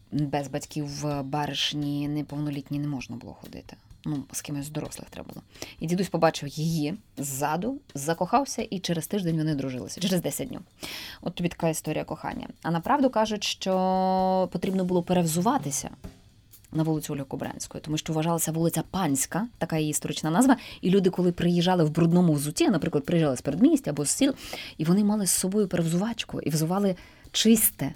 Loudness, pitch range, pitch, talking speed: -26 LUFS, 145-185 Hz, 160 Hz, 165 wpm